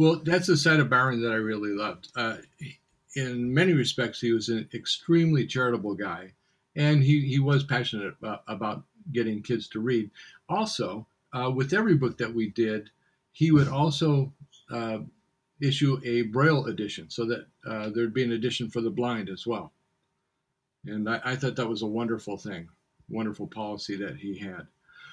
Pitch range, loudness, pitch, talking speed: 110-140 Hz, -27 LUFS, 120 Hz, 175 wpm